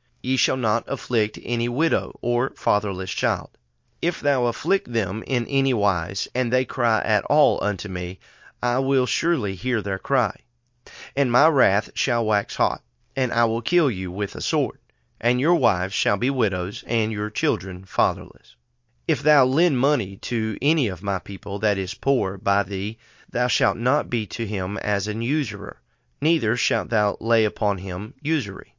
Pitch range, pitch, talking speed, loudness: 100-130 Hz, 115 Hz, 175 wpm, -23 LUFS